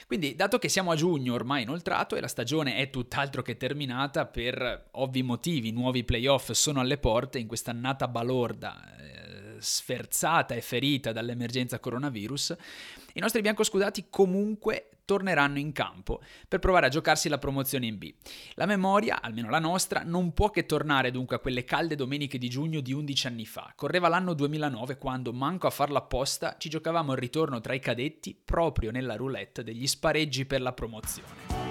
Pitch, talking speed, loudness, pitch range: 140 Hz, 170 wpm, -29 LUFS, 125-160 Hz